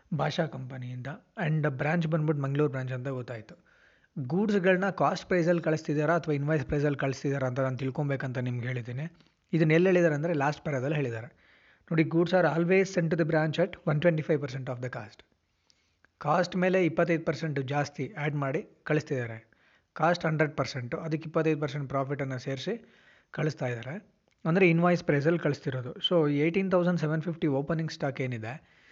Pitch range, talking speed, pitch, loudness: 135-170 Hz, 155 wpm, 155 Hz, -29 LUFS